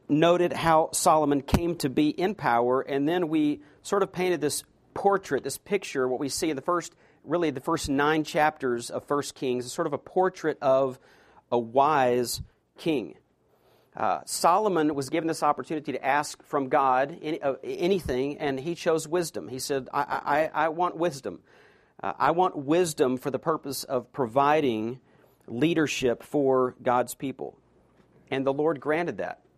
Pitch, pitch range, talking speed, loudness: 145 Hz, 135-165 Hz, 170 wpm, -26 LUFS